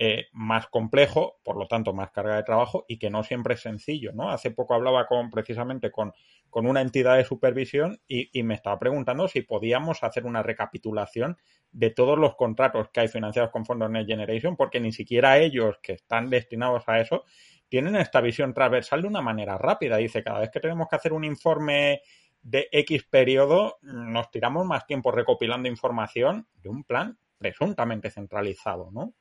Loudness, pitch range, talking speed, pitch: -25 LUFS, 110-140 Hz, 185 wpm, 120 Hz